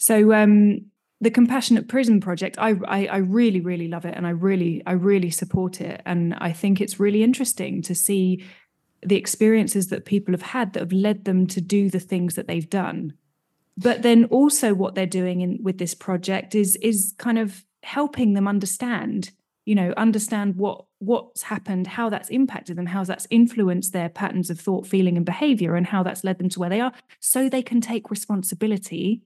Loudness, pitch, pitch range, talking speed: -22 LUFS, 195 Hz, 185-220 Hz, 195 wpm